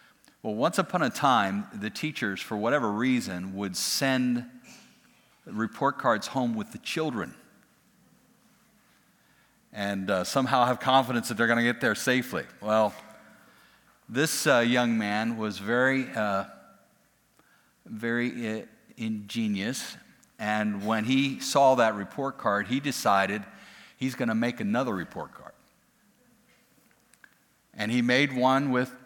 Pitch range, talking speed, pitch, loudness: 110-130 Hz, 130 wpm, 120 Hz, -27 LUFS